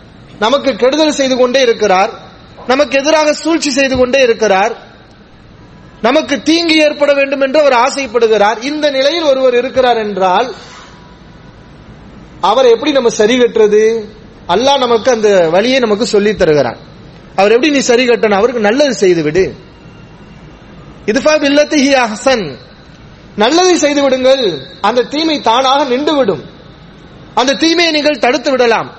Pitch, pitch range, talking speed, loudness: 255 Hz, 215-290 Hz, 110 wpm, -11 LUFS